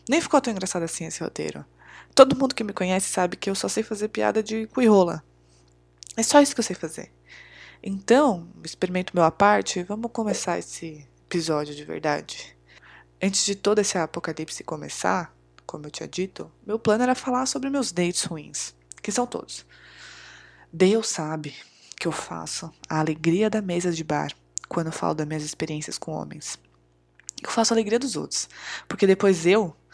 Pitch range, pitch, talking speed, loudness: 145-215 Hz, 175 Hz, 175 wpm, -24 LUFS